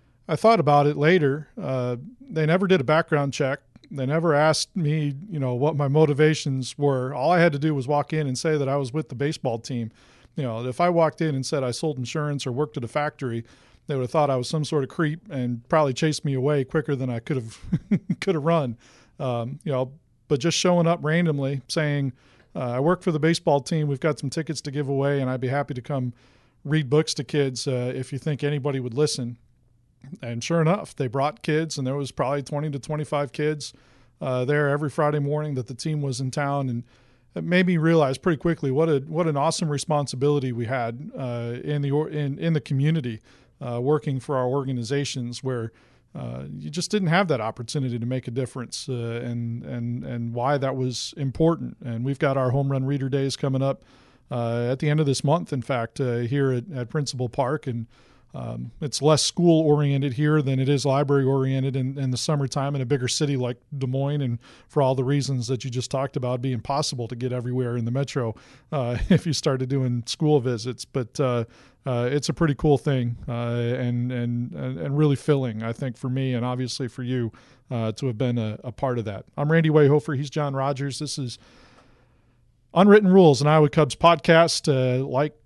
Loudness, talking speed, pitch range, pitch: -24 LUFS, 220 wpm, 125-150 Hz, 140 Hz